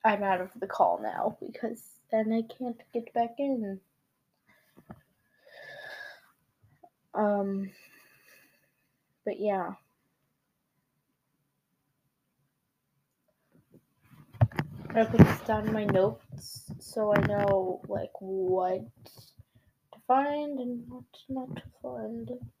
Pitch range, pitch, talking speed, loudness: 155-235 Hz, 200 Hz, 95 wpm, -30 LUFS